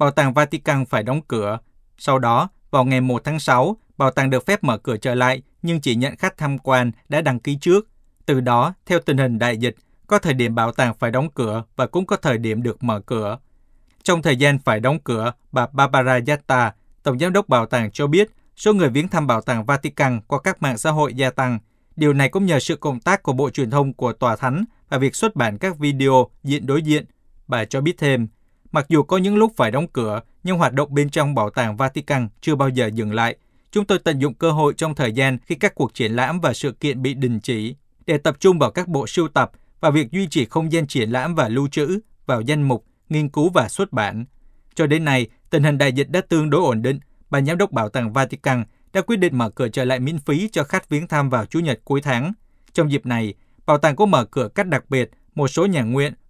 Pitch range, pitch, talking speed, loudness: 125-155 Hz, 140 Hz, 245 wpm, -20 LUFS